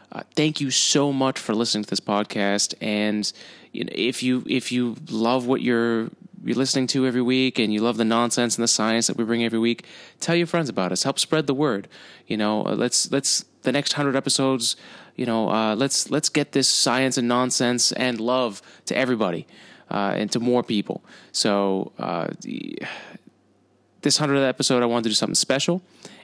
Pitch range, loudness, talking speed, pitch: 110-135 Hz, -22 LUFS, 195 wpm, 125 Hz